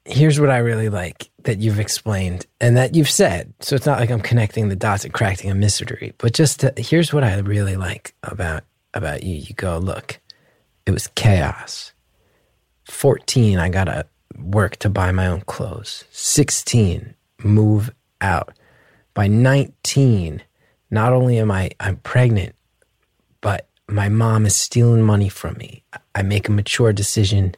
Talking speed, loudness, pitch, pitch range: 165 wpm, -18 LUFS, 110 Hz, 100-120 Hz